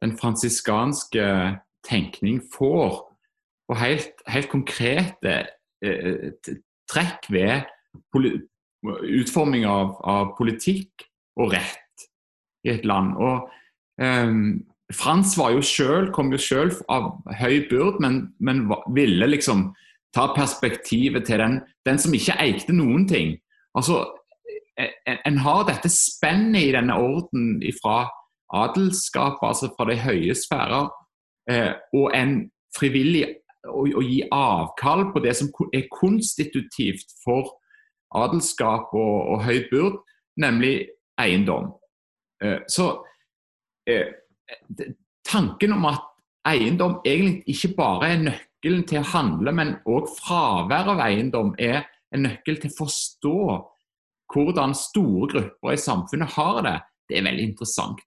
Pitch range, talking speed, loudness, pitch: 125-185 Hz, 125 wpm, -22 LUFS, 145 Hz